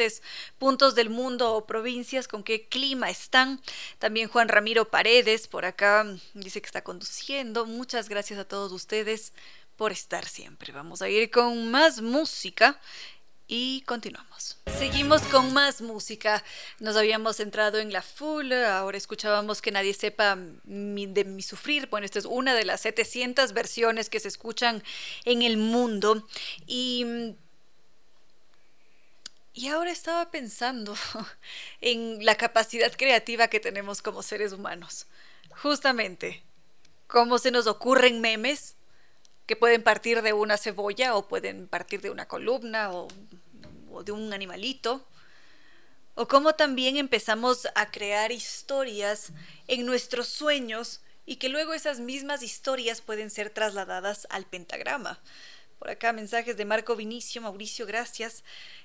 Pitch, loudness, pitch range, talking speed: 225 Hz, -26 LUFS, 210-250 Hz, 135 wpm